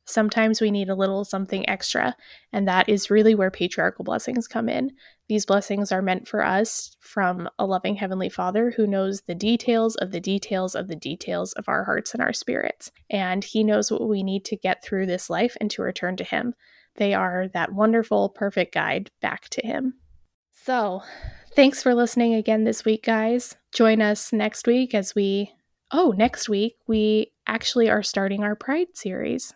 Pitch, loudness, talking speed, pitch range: 215 Hz, -23 LUFS, 185 wpm, 195-230 Hz